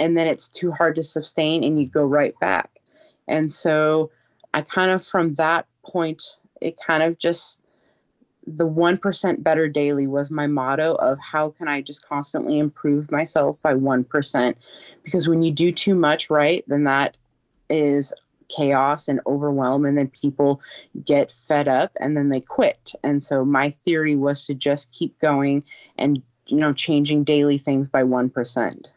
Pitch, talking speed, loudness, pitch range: 150 Hz, 170 wpm, -21 LUFS, 140-160 Hz